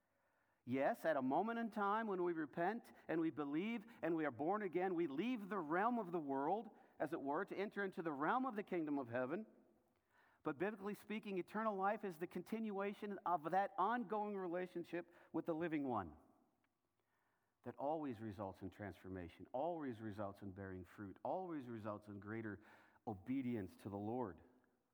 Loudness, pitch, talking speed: -44 LUFS, 170 Hz, 170 wpm